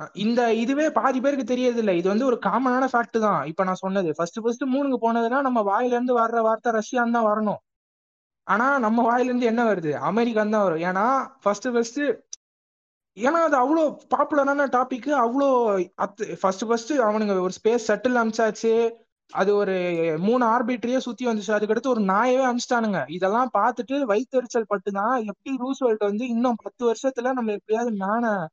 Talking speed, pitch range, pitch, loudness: 150 wpm, 205-255 Hz, 230 Hz, -23 LUFS